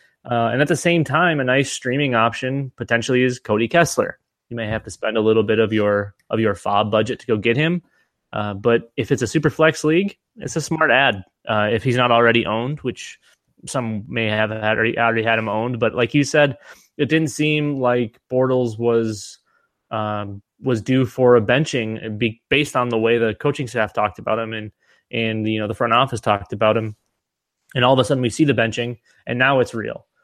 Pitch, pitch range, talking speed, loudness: 120 Hz, 110-135 Hz, 215 wpm, -19 LUFS